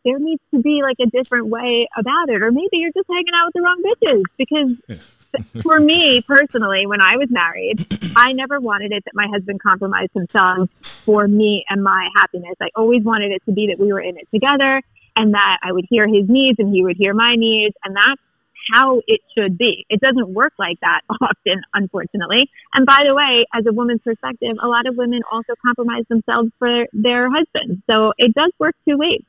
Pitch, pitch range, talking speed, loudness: 235 Hz, 205-270 Hz, 215 wpm, -15 LUFS